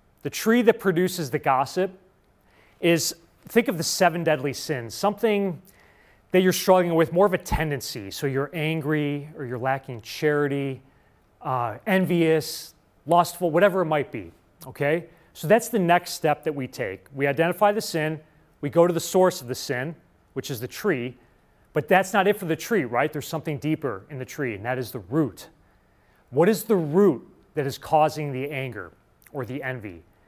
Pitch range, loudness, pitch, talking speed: 135-175 Hz, -24 LUFS, 155 Hz, 180 wpm